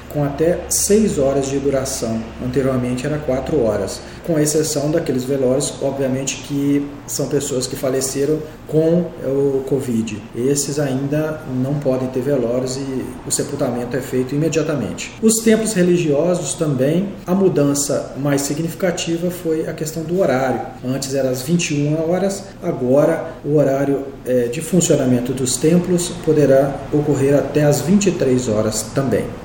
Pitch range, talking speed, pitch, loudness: 130-160 Hz, 135 wpm, 140 Hz, -18 LUFS